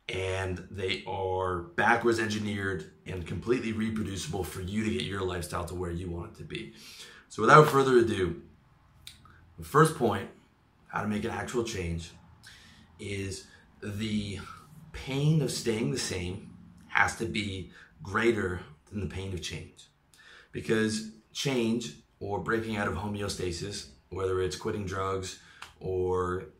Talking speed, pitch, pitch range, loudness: 140 wpm, 95 Hz, 90-110 Hz, -30 LUFS